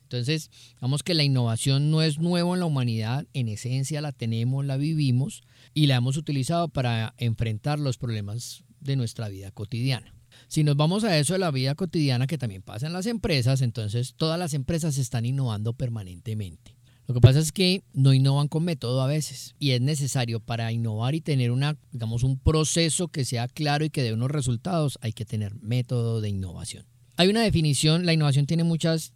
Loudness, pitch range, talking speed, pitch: -25 LUFS, 120-155 Hz, 195 wpm, 130 Hz